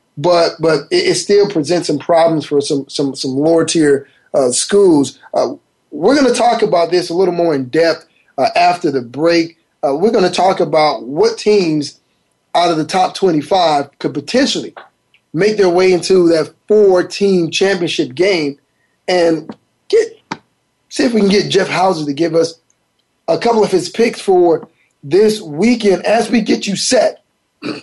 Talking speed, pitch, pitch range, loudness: 175 wpm, 180 Hz, 160-210 Hz, -14 LUFS